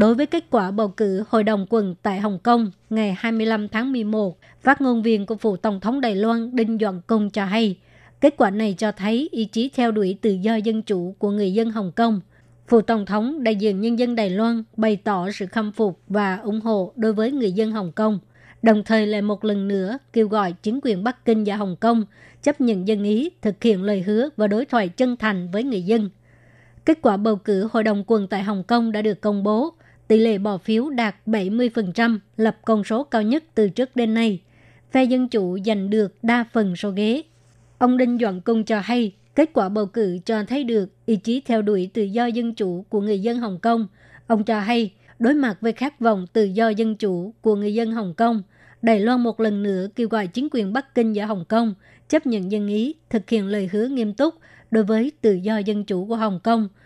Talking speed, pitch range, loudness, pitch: 230 wpm, 205-230 Hz, -21 LUFS, 220 Hz